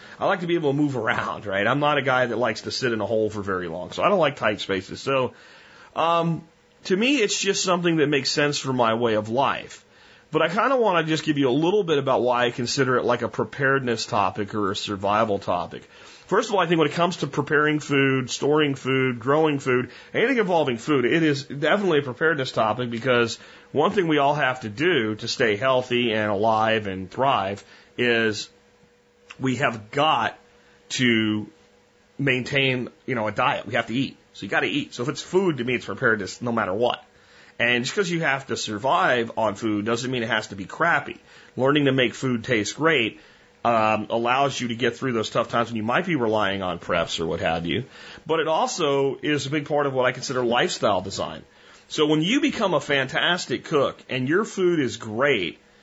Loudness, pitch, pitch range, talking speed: -23 LUFS, 130 Hz, 115-150 Hz, 220 wpm